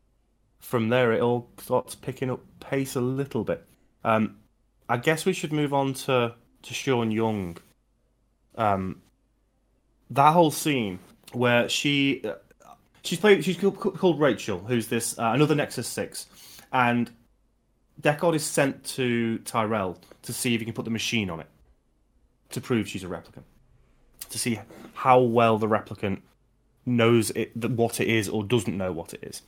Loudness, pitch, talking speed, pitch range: -25 LUFS, 120 Hz, 155 wpm, 110-130 Hz